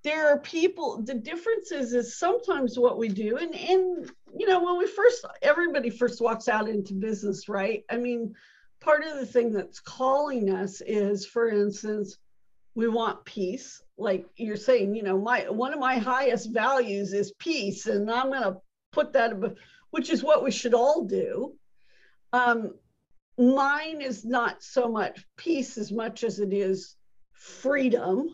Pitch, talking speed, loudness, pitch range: 245 Hz, 165 wpm, -27 LUFS, 210-290 Hz